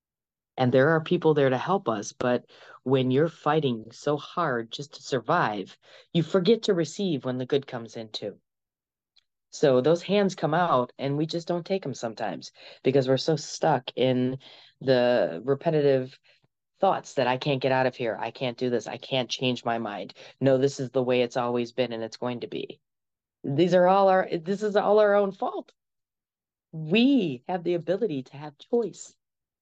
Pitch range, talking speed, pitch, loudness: 125-175 Hz, 190 wpm, 140 Hz, -26 LUFS